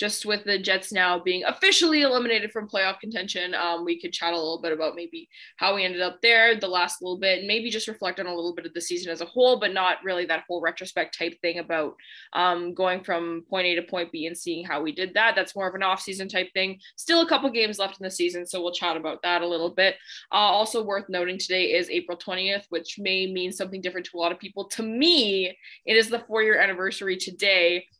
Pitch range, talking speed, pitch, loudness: 175-200 Hz, 250 wpm, 185 Hz, -24 LUFS